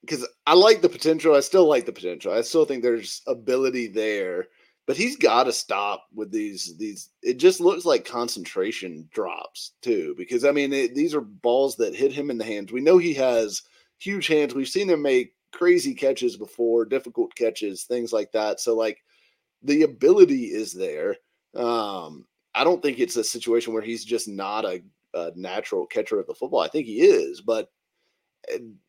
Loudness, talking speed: -23 LUFS, 190 wpm